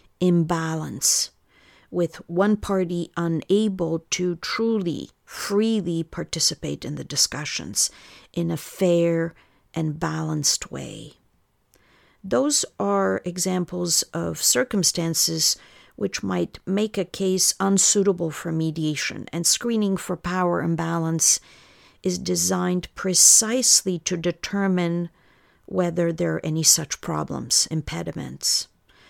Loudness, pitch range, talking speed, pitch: -22 LUFS, 165-190 Hz, 100 wpm, 175 Hz